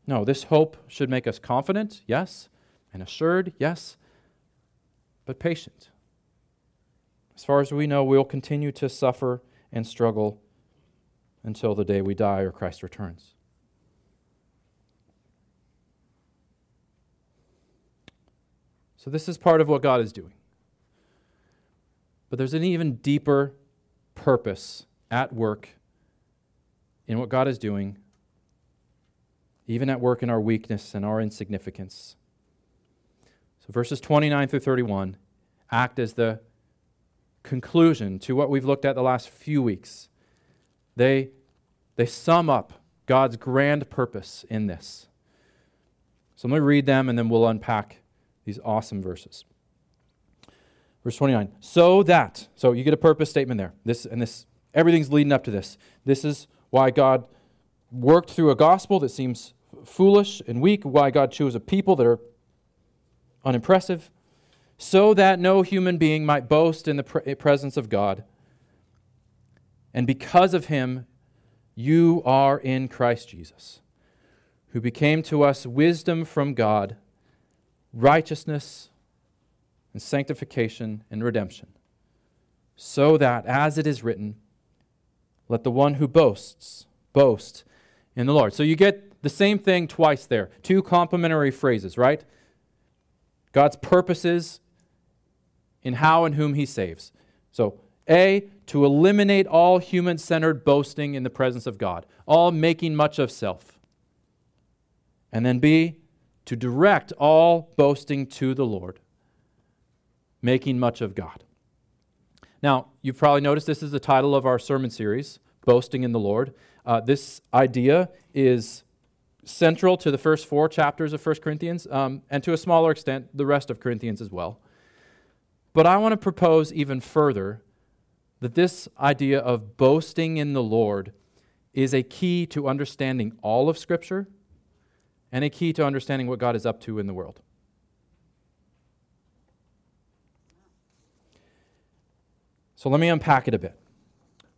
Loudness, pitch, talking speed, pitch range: -22 LUFS, 135 Hz, 135 wpm, 115-155 Hz